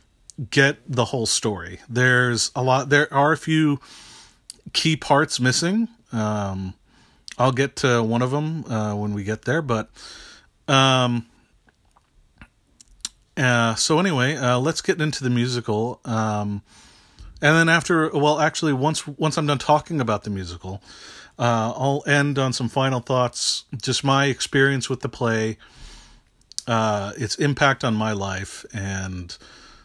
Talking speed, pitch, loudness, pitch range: 145 wpm, 125 Hz, -21 LUFS, 110-145 Hz